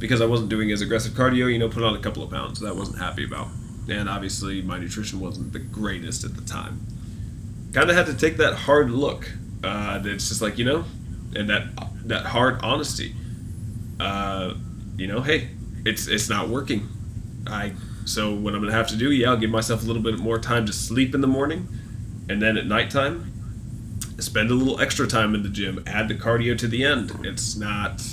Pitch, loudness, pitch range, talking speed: 110 Hz, -24 LUFS, 105-120 Hz, 210 wpm